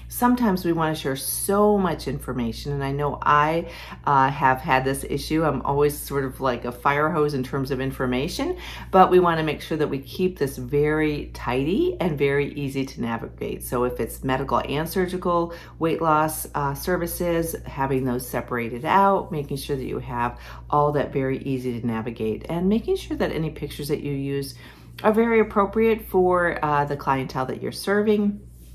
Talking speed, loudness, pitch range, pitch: 190 wpm, -23 LUFS, 135-170 Hz, 145 Hz